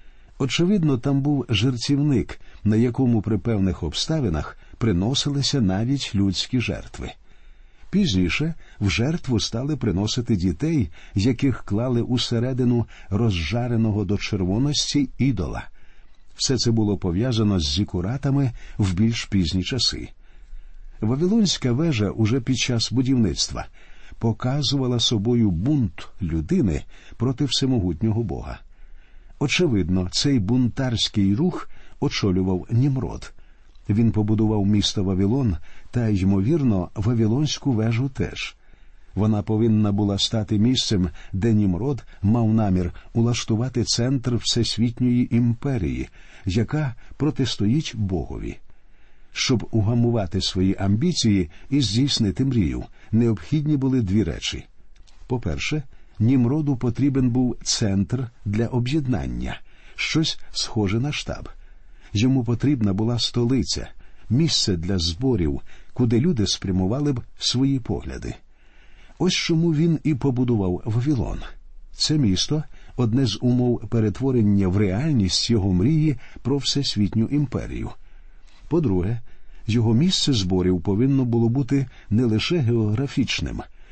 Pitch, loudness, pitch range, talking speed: 115 Hz, -22 LUFS, 100-130 Hz, 105 wpm